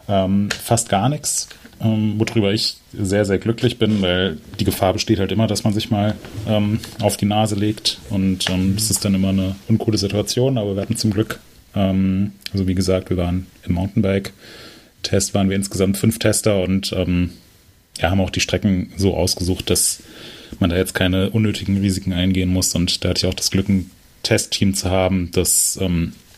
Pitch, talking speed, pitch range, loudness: 100 Hz, 190 wpm, 95-110 Hz, -19 LUFS